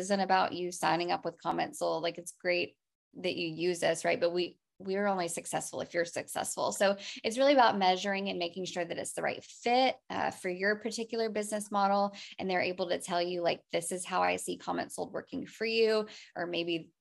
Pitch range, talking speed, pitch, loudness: 170-200 Hz, 220 wpm, 185 Hz, -32 LUFS